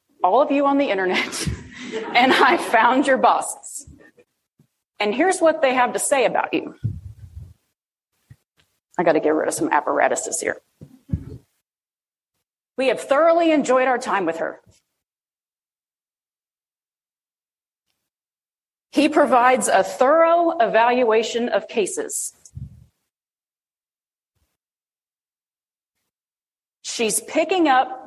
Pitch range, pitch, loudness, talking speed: 230-315 Hz, 260 Hz, -19 LUFS, 100 wpm